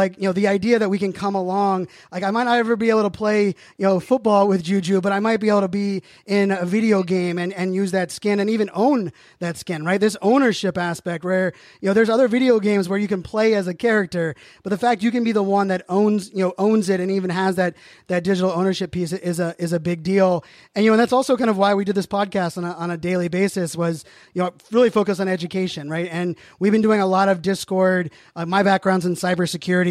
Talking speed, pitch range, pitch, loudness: 265 wpm, 180-210 Hz, 195 Hz, -20 LUFS